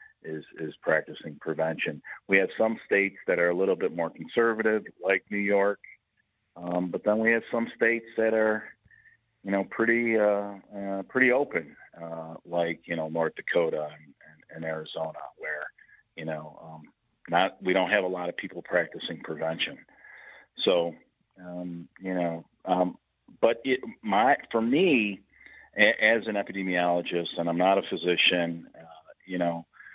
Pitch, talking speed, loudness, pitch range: 90 Hz, 160 wpm, -27 LUFS, 85-110 Hz